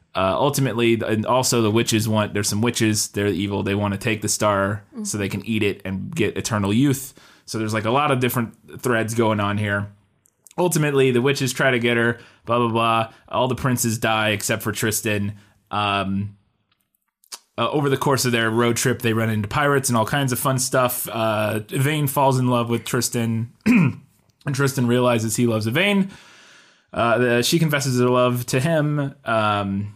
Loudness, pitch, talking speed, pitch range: -21 LUFS, 115 Hz, 190 wpm, 105-130 Hz